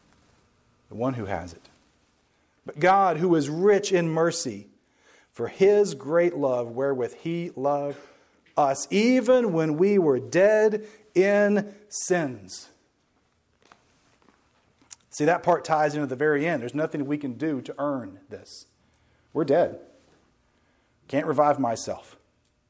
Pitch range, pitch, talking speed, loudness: 135-190 Hz, 155 Hz, 125 wpm, -24 LUFS